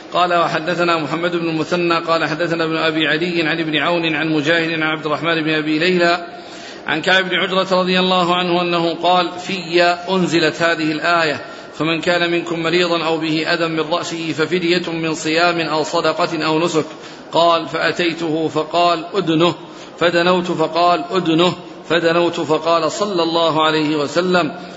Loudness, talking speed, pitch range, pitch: -17 LUFS, 155 wpm, 160-175 Hz, 170 Hz